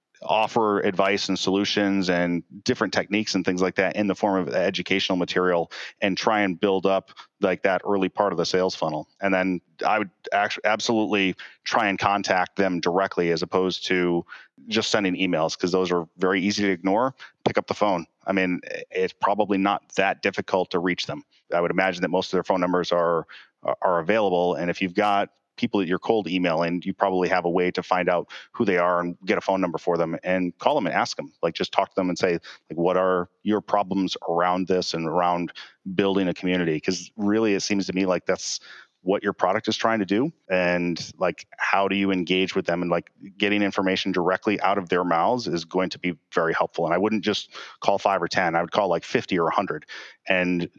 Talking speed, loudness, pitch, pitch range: 220 wpm, -24 LUFS, 95 Hz, 90-100 Hz